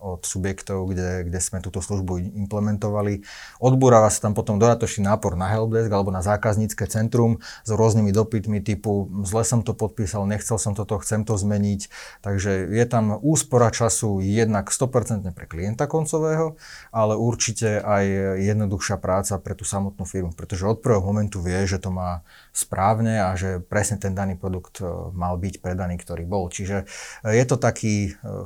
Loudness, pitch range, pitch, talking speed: -23 LUFS, 95-110 Hz, 105 Hz, 160 wpm